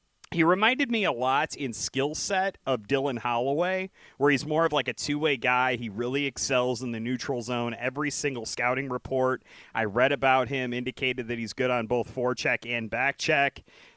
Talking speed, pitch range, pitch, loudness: 190 wpm, 125-145 Hz, 130 Hz, -27 LUFS